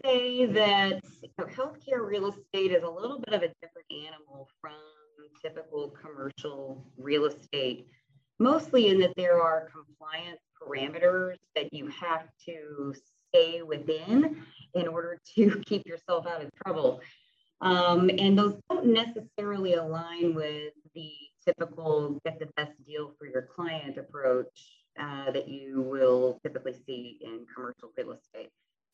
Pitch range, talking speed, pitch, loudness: 145-195 Hz, 140 wpm, 165 Hz, -29 LUFS